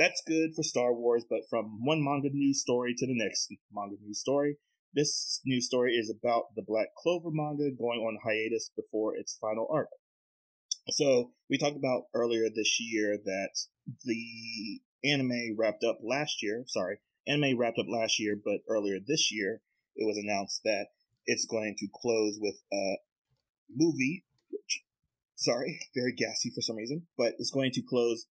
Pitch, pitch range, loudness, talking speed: 120 Hz, 110-145 Hz, -31 LUFS, 170 wpm